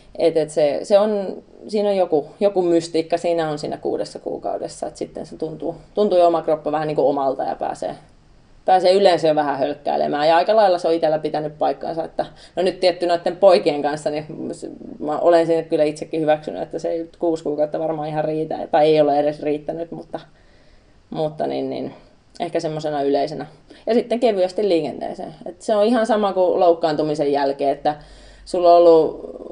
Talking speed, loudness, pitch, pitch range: 185 wpm, -19 LUFS, 160 Hz, 150-180 Hz